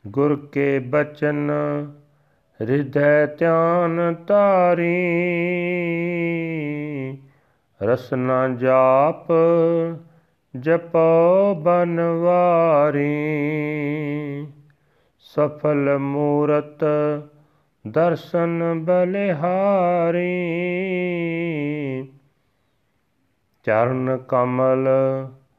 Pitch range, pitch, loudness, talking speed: 140-170 Hz, 150 Hz, -20 LUFS, 40 wpm